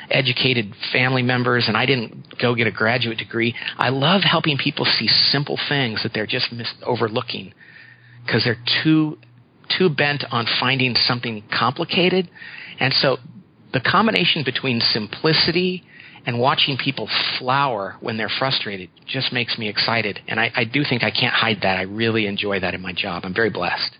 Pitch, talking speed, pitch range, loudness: 120 Hz, 170 wpm, 110-140 Hz, -19 LUFS